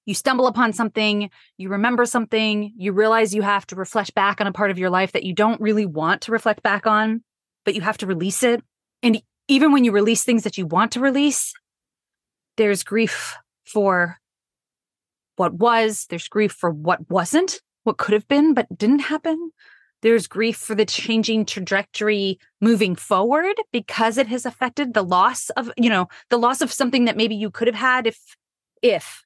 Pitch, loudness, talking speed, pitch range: 220 Hz, -20 LUFS, 190 wpm, 200-245 Hz